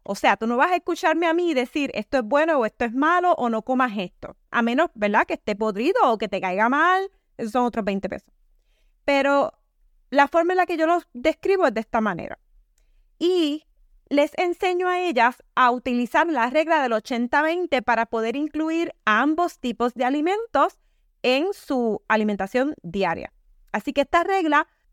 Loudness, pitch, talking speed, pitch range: -22 LUFS, 285 Hz, 185 wpm, 235-330 Hz